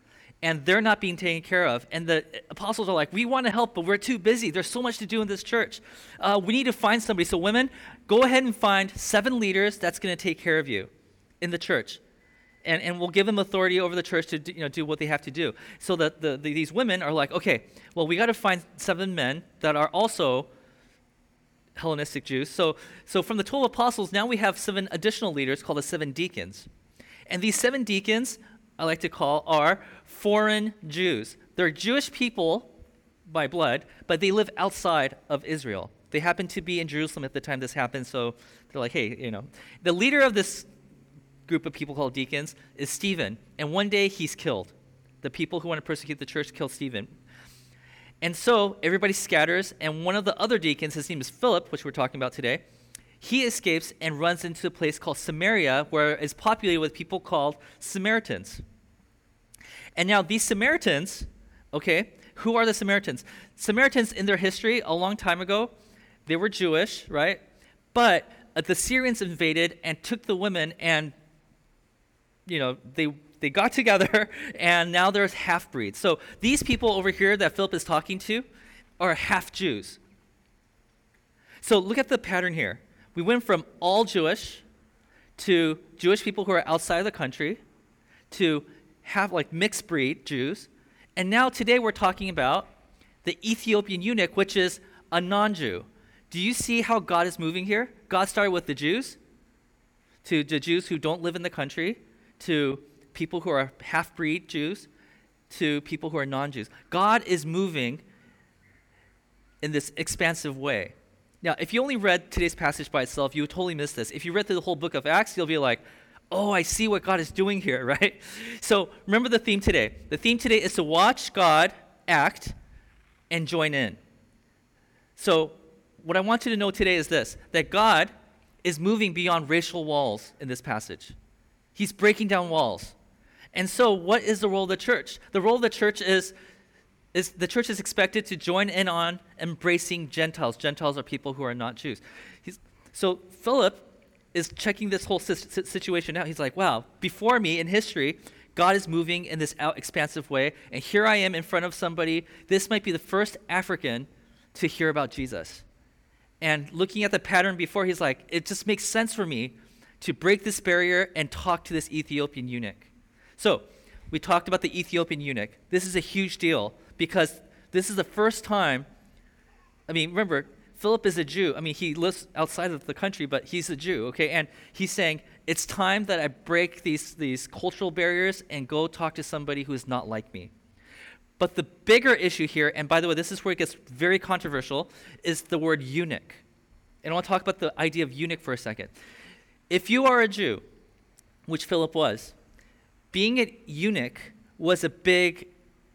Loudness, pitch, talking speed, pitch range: -26 LUFS, 175 Hz, 190 wpm, 155-200 Hz